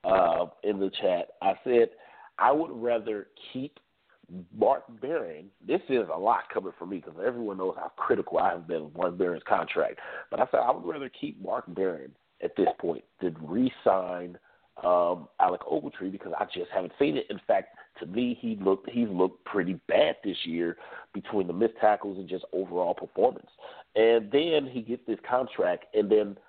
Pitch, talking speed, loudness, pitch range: 115 Hz, 185 wpm, -29 LUFS, 95-130 Hz